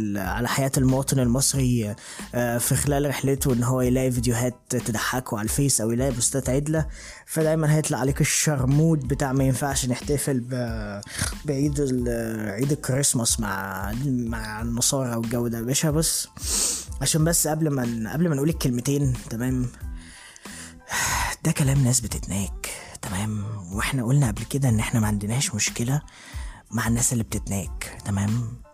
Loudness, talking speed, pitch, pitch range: -24 LUFS, 135 wpm, 125 Hz, 110-140 Hz